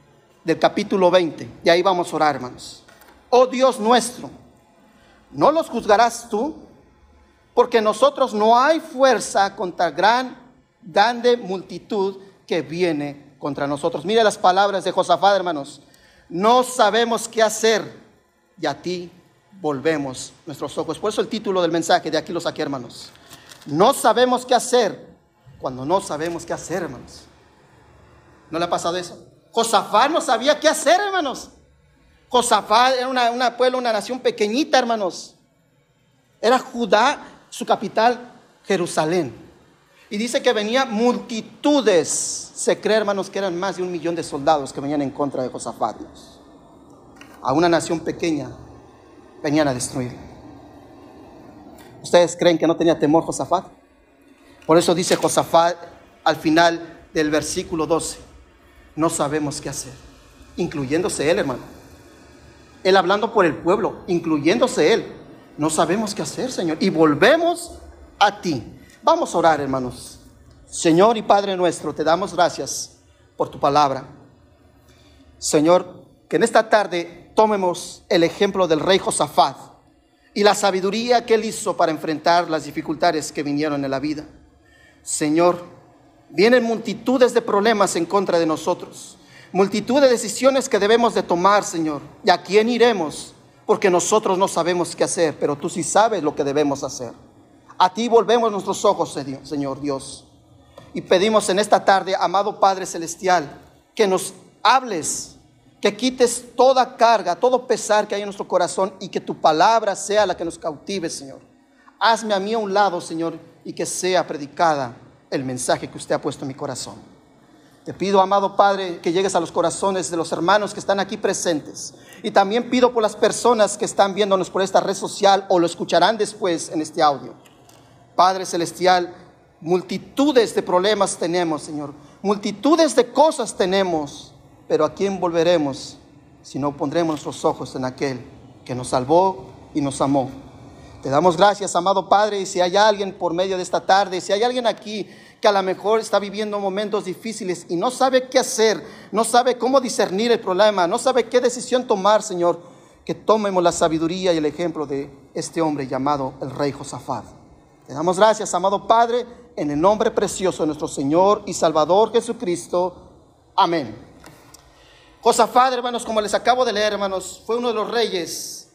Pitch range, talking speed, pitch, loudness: 160-220 Hz, 160 wpm, 185 Hz, -19 LUFS